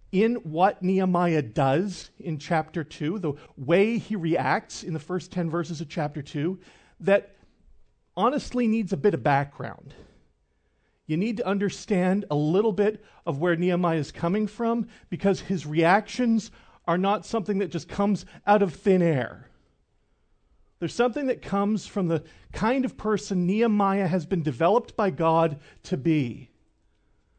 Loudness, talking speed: -26 LUFS, 150 wpm